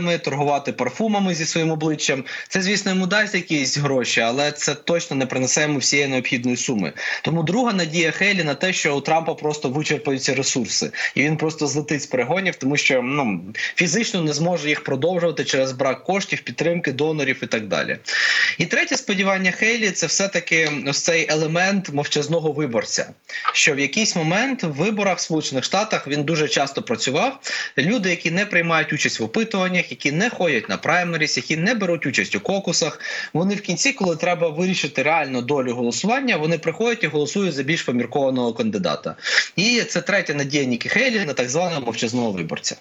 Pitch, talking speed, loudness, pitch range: 165 Hz, 170 wpm, -20 LUFS, 145-185 Hz